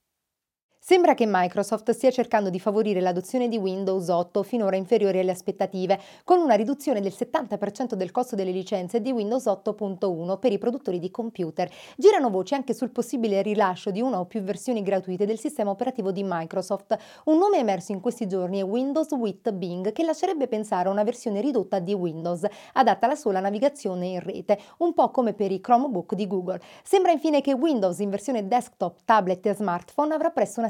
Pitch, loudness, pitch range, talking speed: 210 Hz, -25 LUFS, 190-250 Hz, 185 wpm